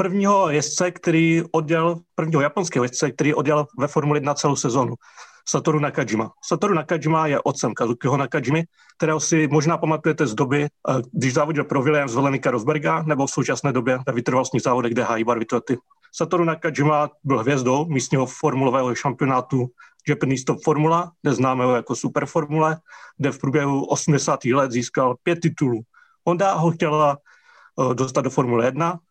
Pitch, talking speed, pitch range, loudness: 150 Hz, 155 wpm, 130-160 Hz, -21 LUFS